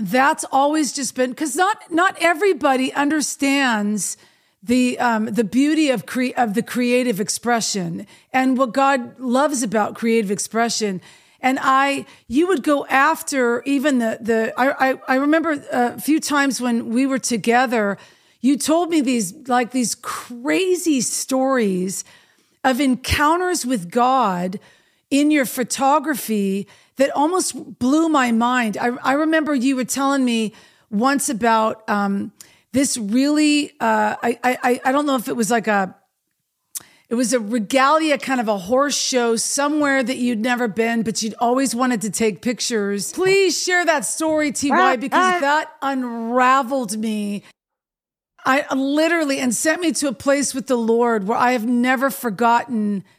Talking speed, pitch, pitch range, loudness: 150 wpm, 255 Hz, 230-280 Hz, -19 LUFS